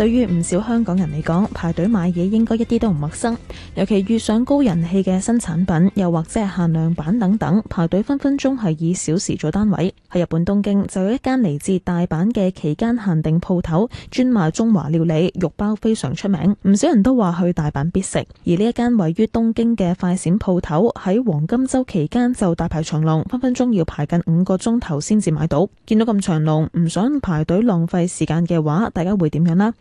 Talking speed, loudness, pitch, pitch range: 310 characters per minute, -18 LUFS, 185 Hz, 165-225 Hz